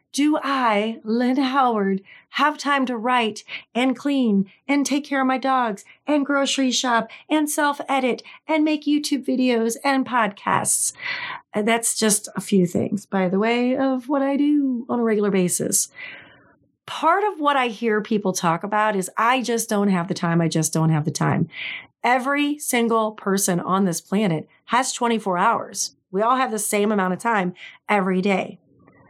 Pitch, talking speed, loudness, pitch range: 235 Hz, 175 wpm, -21 LUFS, 200-275 Hz